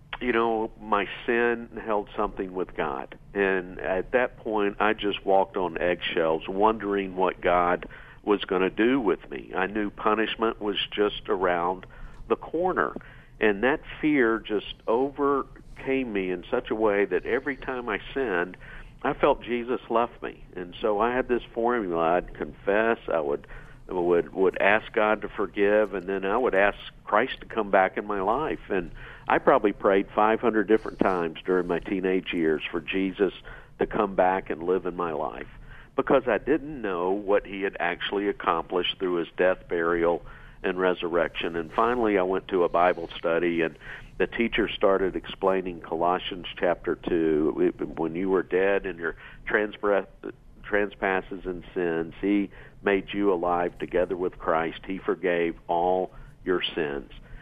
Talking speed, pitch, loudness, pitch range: 160 wpm, 100 Hz, -26 LUFS, 90-110 Hz